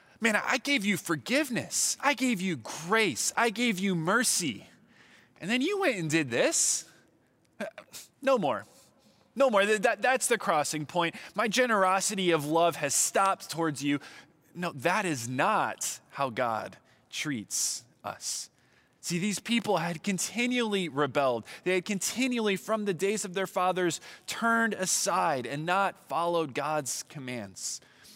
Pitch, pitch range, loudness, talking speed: 190 Hz, 165-225 Hz, -28 LUFS, 145 wpm